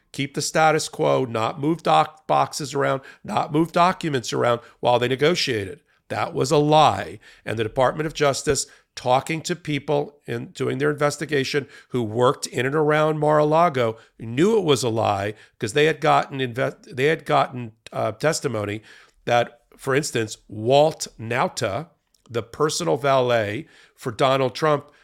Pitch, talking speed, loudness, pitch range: 145 Hz, 150 wpm, -22 LUFS, 120-155 Hz